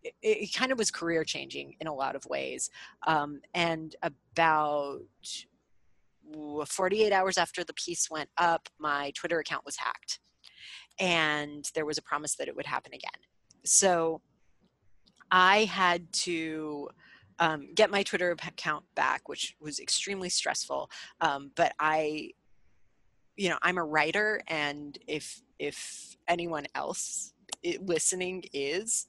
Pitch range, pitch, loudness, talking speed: 150-185 Hz, 165 Hz, -30 LUFS, 135 wpm